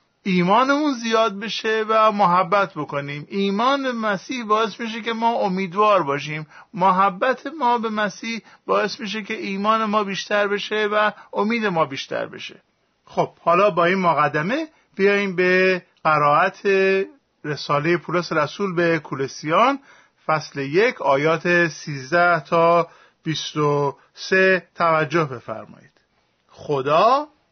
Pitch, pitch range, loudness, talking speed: 190 Hz, 160-220 Hz, -20 LUFS, 120 wpm